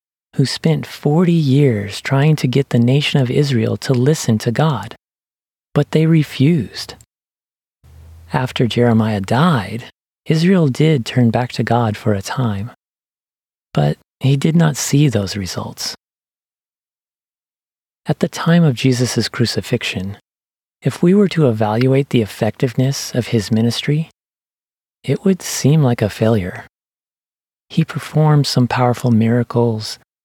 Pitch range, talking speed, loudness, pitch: 115-150 Hz, 125 wpm, -16 LUFS, 125 Hz